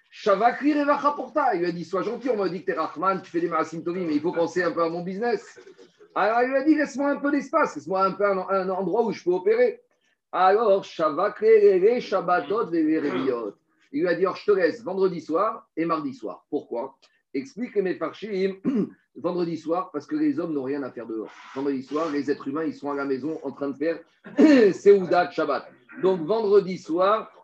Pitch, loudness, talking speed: 190 Hz, -24 LUFS, 205 wpm